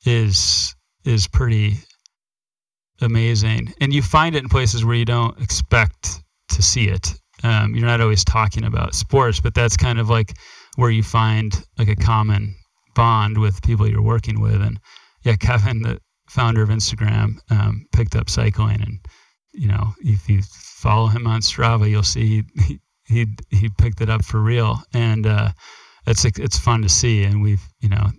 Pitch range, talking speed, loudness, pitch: 105-115 Hz, 175 wpm, -18 LUFS, 110 Hz